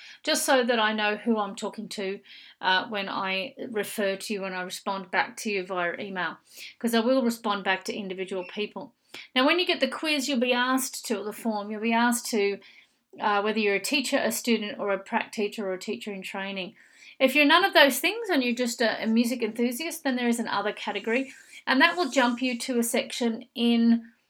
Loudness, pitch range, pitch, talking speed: -26 LUFS, 205-255 Hz, 230 Hz, 220 wpm